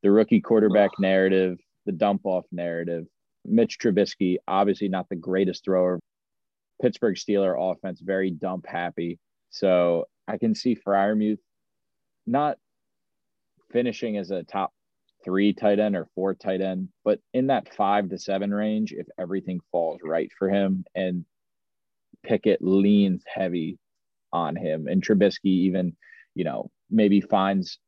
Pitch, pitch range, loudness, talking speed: 95 Hz, 90-100 Hz, -25 LUFS, 140 wpm